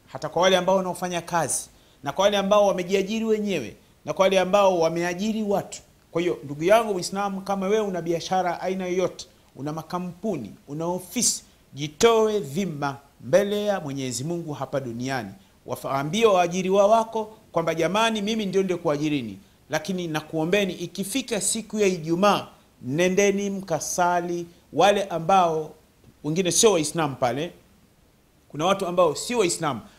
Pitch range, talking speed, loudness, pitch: 155-200 Hz, 135 wpm, -24 LUFS, 180 Hz